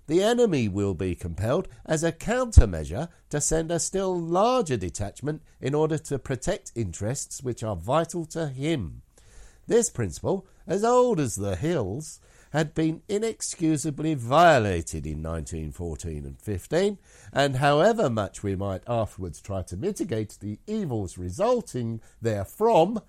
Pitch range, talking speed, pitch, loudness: 100-165 Hz, 135 wpm, 130 Hz, -26 LUFS